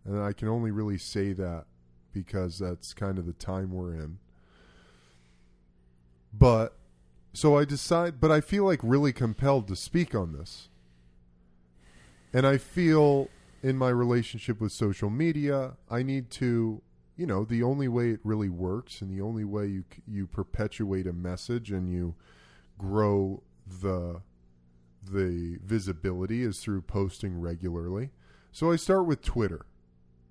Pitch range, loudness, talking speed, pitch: 80-120 Hz, -29 LUFS, 145 wpm, 95 Hz